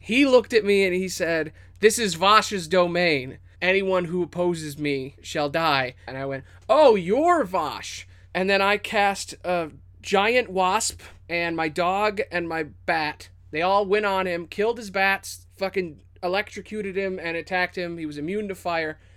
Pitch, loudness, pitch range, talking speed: 175 Hz, -23 LUFS, 145-195 Hz, 170 wpm